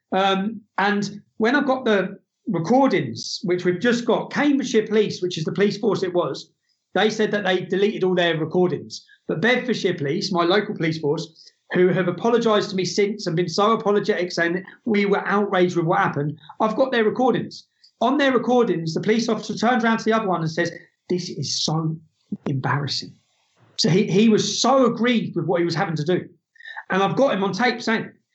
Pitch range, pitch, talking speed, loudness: 180-220 Hz, 200 Hz, 200 wpm, -21 LUFS